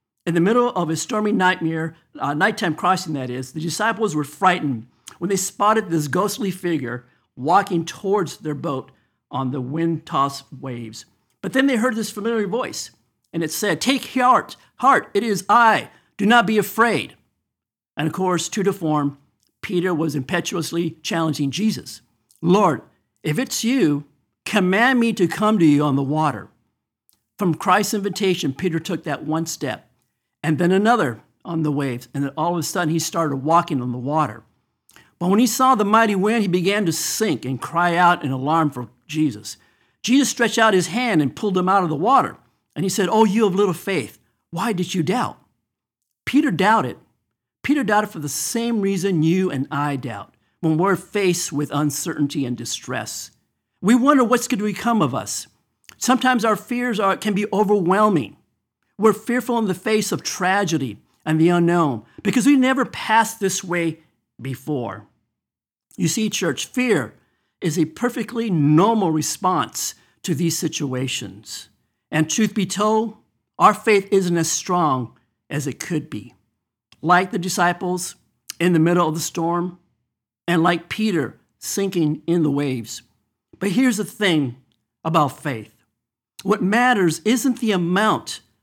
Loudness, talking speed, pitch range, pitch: -20 LUFS, 165 wpm, 145-210 Hz, 175 Hz